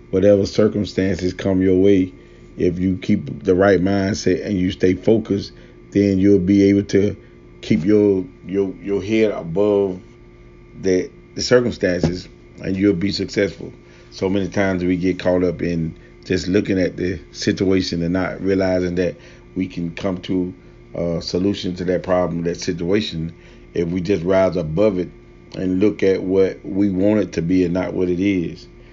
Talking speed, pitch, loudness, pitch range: 170 wpm, 95 Hz, -19 LUFS, 90-100 Hz